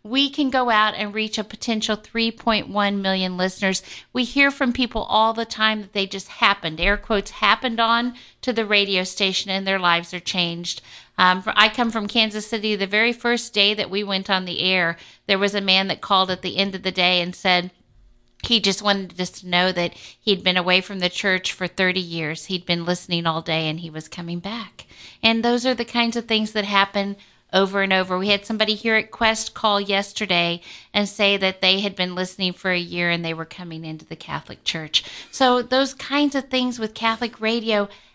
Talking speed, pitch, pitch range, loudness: 215 wpm, 200 Hz, 185-220 Hz, -21 LUFS